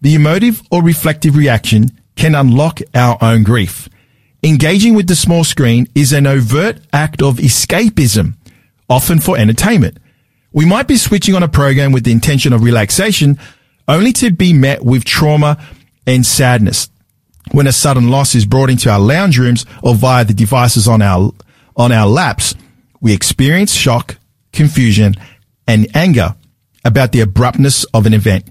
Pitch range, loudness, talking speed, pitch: 115-150 Hz, -10 LUFS, 160 wpm, 130 Hz